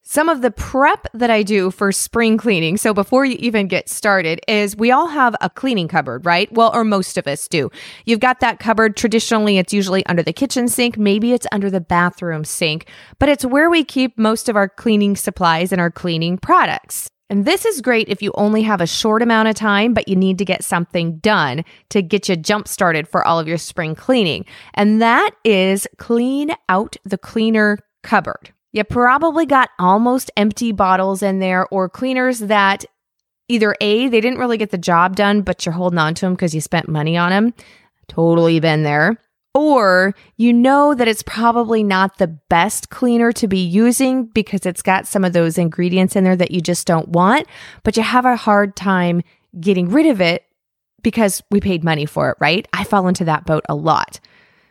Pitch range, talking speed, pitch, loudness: 180-230 Hz, 205 wpm, 205 Hz, -16 LUFS